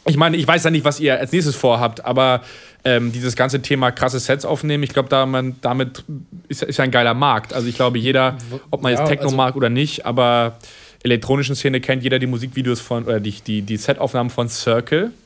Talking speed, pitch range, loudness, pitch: 210 wpm, 120-140 Hz, -18 LUFS, 130 Hz